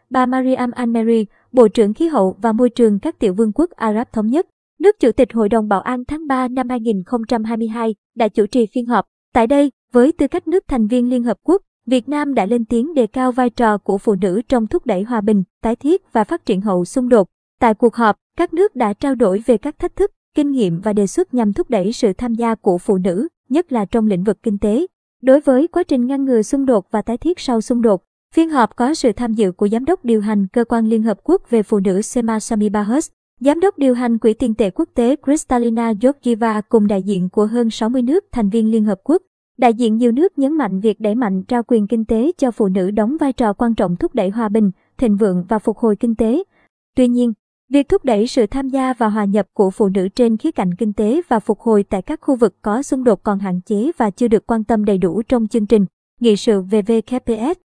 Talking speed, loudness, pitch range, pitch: 245 wpm, -17 LUFS, 215-260 Hz, 235 Hz